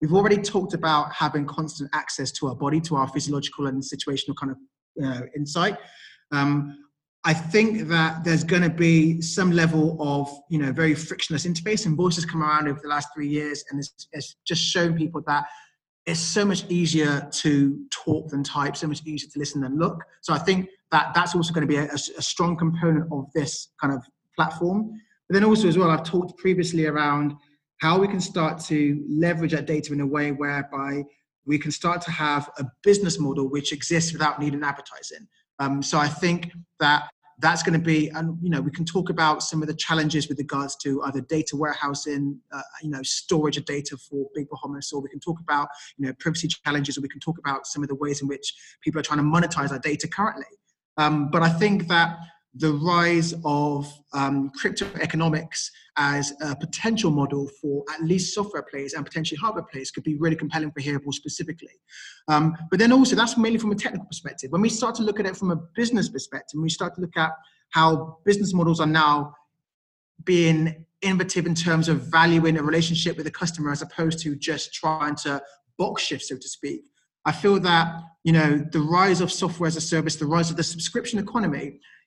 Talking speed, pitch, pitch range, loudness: 210 wpm, 155 Hz, 145-170 Hz, -24 LUFS